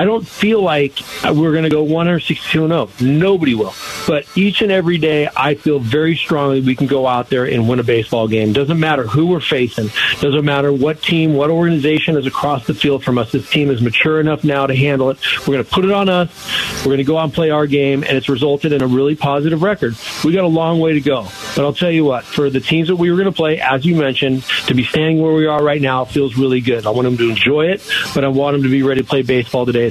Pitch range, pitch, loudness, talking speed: 130-160 Hz, 145 Hz, -15 LUFS, 270 wpm